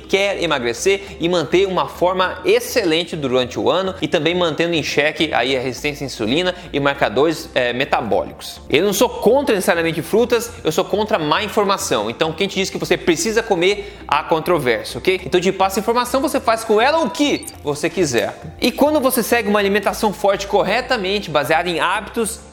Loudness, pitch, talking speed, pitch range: -18 LUFS, 190 Hz, 185 wpm, 165-225 Hz